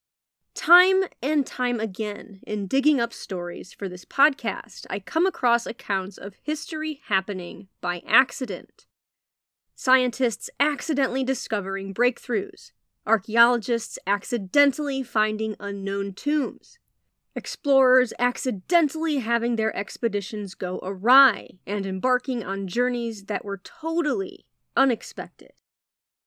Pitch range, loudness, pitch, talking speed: 205-280 Hz, -24 LUFS, 235 Hz, 100 wpm